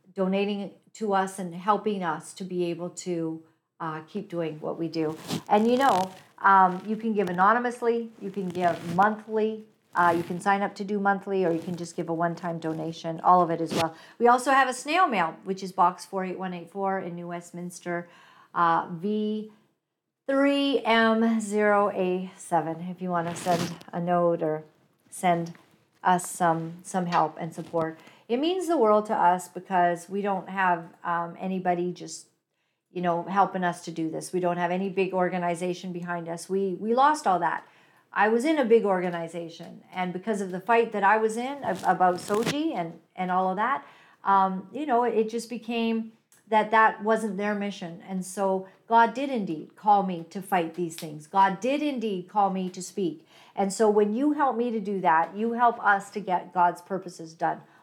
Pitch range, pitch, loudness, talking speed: 175-210 Hz, 185 Hz, -26 LUFS, 190 wpm